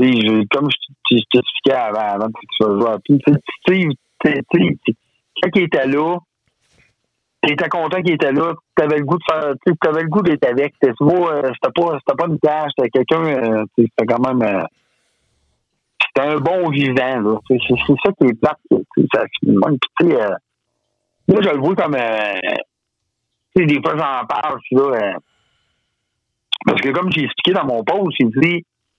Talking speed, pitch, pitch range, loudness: 165 wpm, 145 Hz, 125-170 Hz, -16 LUFS